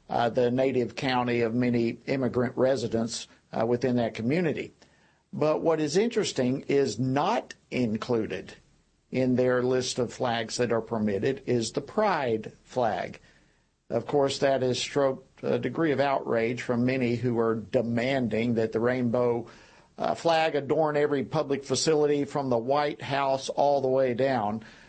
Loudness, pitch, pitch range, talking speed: -27 LUFS, 125 Hz, 120-140 Hz, 150 wpm